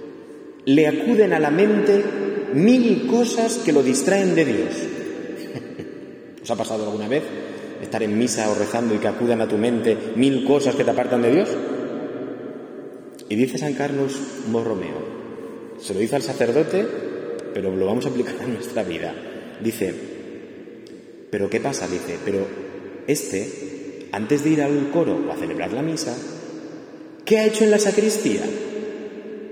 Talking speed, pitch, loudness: 155 wpm, 140 Hz, -21 LUFS